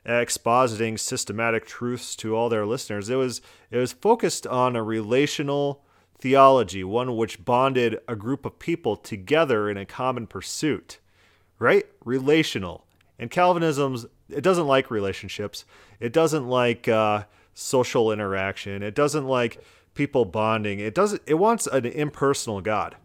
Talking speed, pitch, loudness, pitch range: 140 wpm, 120 Hz, -24 LUFS, 110-140 Hz